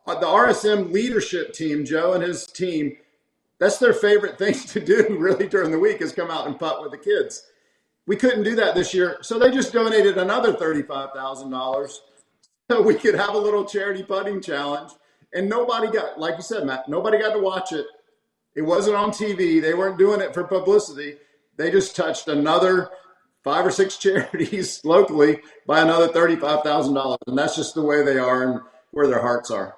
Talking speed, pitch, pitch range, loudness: 190 wpm, 185 Hz, 150-210 Hz, -21 LUFS